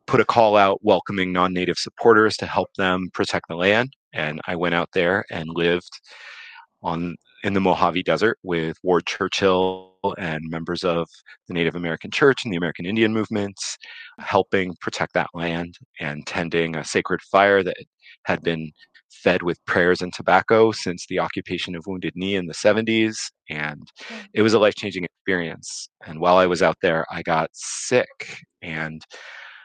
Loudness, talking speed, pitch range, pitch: -22 LUFS, 165 wpm, 85-100 Hz, 90 Hz